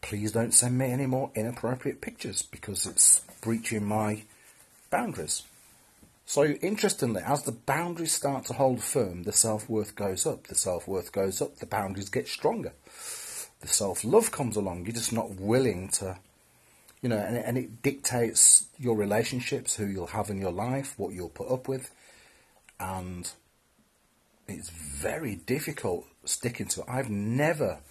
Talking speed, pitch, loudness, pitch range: 160 wpm, 115 Hz, -27 LUFS, 105-135 Hz